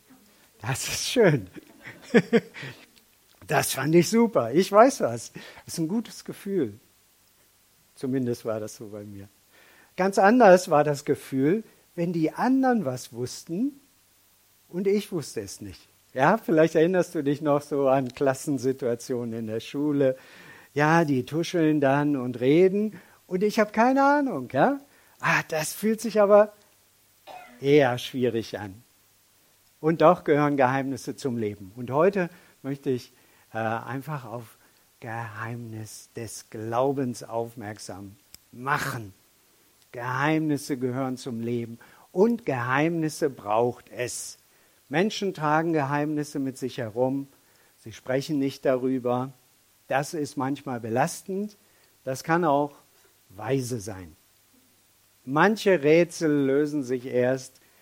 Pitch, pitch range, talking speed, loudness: 135 Hz, 115-165 Hz, 120 wpm, -25 LUFS